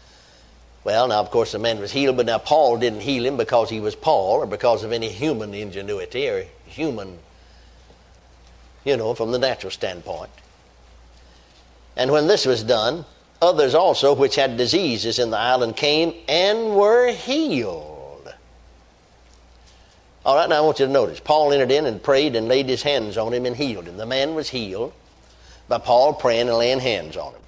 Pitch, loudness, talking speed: 115 Hz, -20 LUFS, 180 wpm